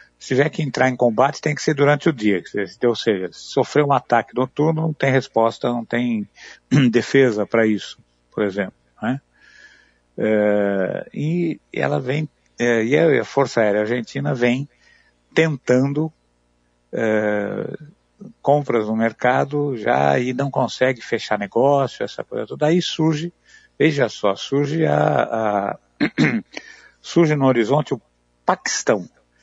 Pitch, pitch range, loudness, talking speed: 130 Hz, 105-150 Hz, -20 LUFS, 130 wpm